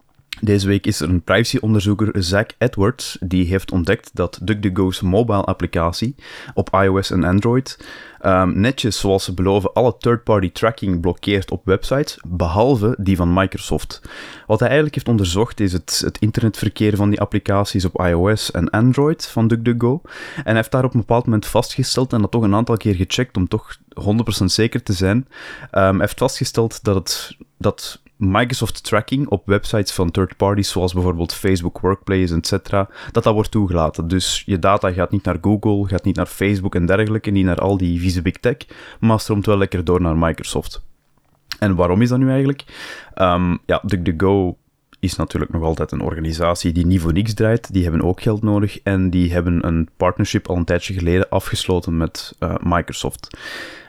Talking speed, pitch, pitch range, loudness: 175 wpm, 100 Hz, 90-110 Hz, -18 LUFS